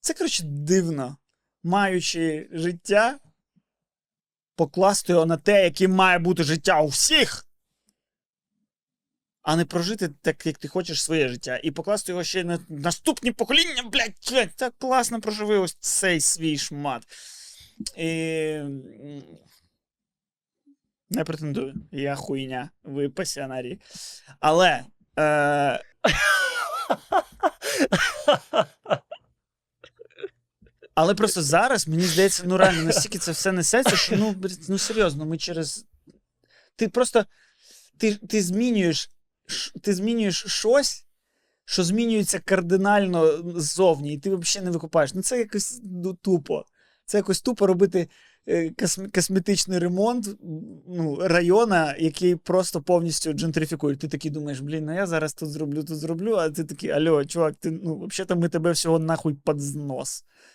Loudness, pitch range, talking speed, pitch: -23 LUFS, 160-205 Hz, 120 wpm, 180 Hz